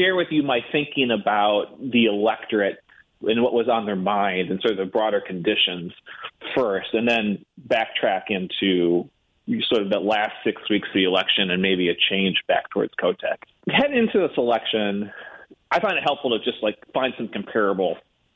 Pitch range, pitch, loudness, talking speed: 95-120 Hz, 105 Hz, -22 LUFS, 180 wpm